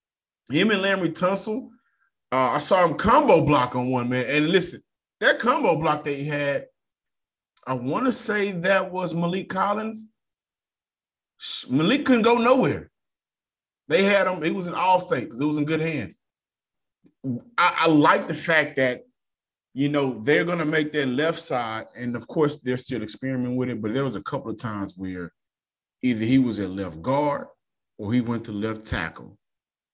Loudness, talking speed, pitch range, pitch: -23 LUFS, 180 wpm, 125-185 Hz, 150 Hz